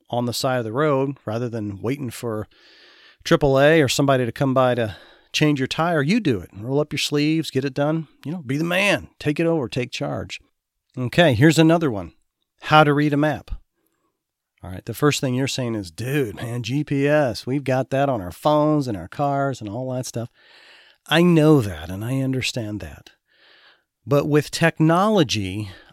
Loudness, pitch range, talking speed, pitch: -21 LUFS, 115-150 Hz, 190 wpm, 135 Hz